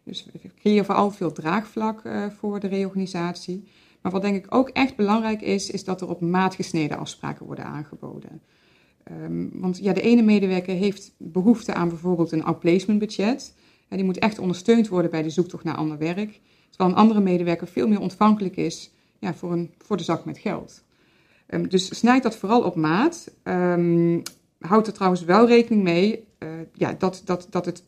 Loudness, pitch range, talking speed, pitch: -23 LUFS, 175-210 Hz, 185 wpm, 185 Hz